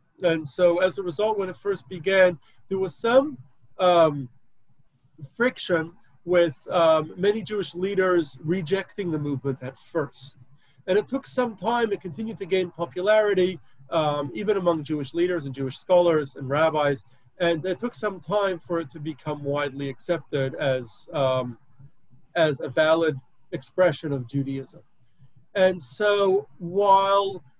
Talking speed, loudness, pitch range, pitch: 145 wpm, -24 LUFS, 140-190 Hz, 165 Hz